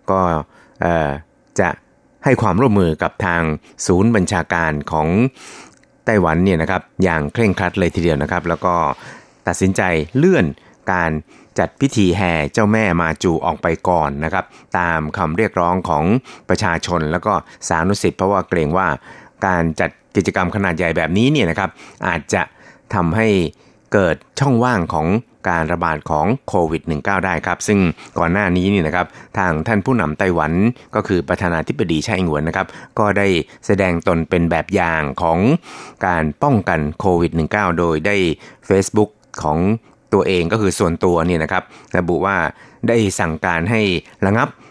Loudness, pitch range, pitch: -17 LUFS, 80-100 Hz, 90 Hz